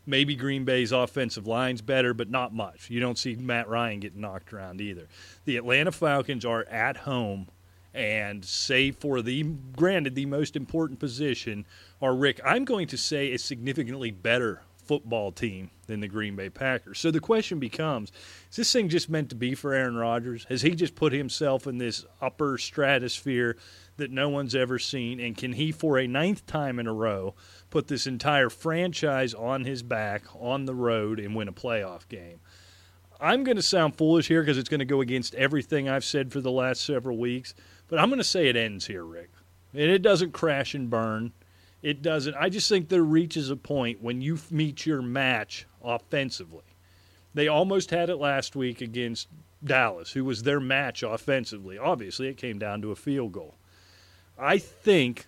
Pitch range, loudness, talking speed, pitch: 110-145 Hz, -27 LUFS, 190 wpm, 130 Hz